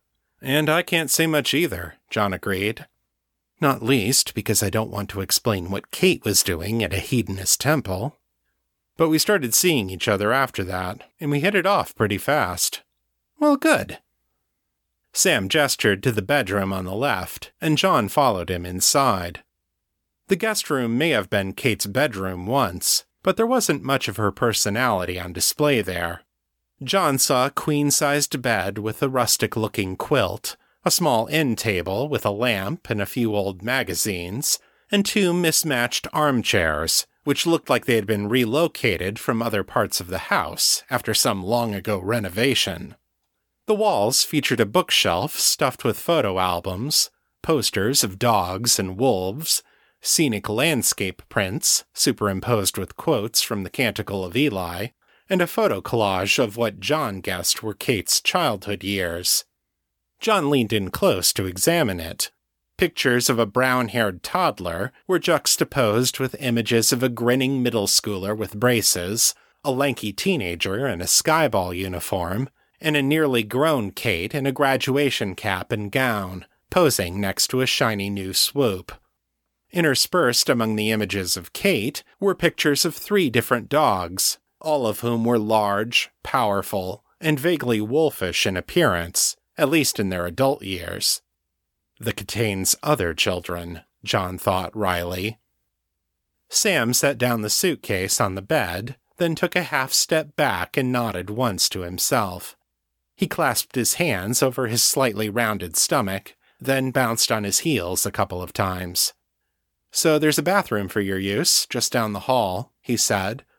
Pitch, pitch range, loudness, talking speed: 115 Hz, 95-140 Hz, -21 LUFS, 155 wpm